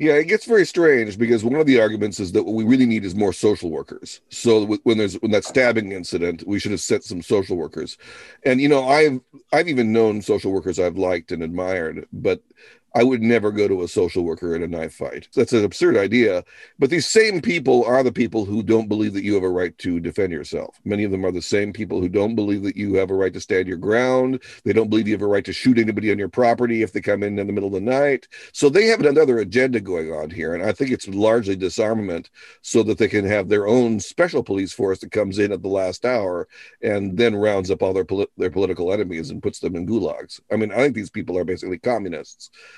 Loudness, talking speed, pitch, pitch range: -20 LUFS, 250 wpm, 105 Hz, 95-120 Hz